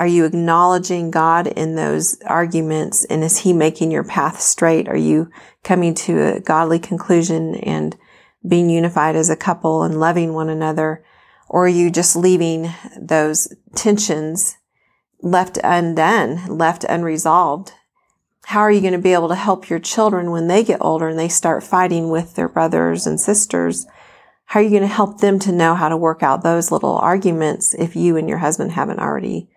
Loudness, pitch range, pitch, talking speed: -16 LUFS, 160-180 Hz, 165 Hz, 180 wpm